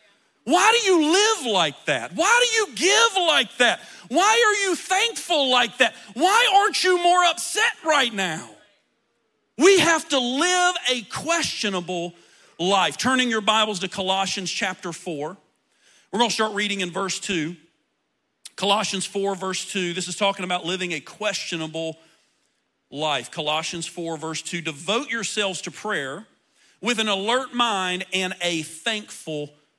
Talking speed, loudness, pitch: 150 wpm, -21 LUFS, 205 Hz